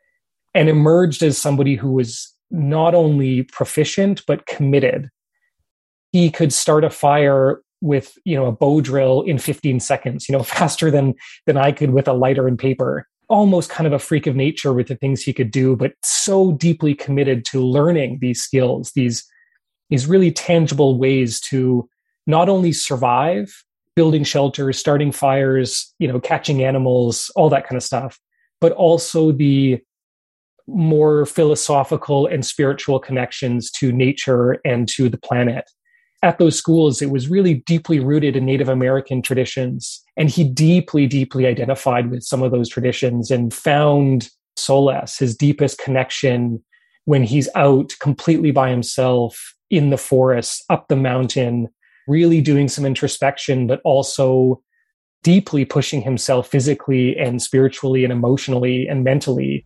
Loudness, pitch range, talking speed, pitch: -17 LUFS, 130-155 Hz, 150 wpm, 135 Hz